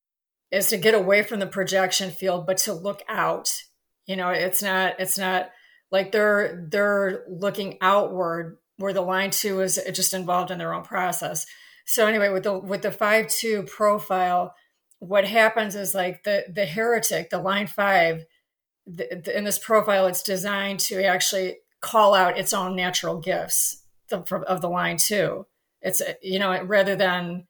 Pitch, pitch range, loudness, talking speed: 195 Hz, 185-205 Hz, -23 LUFS, 170 wpm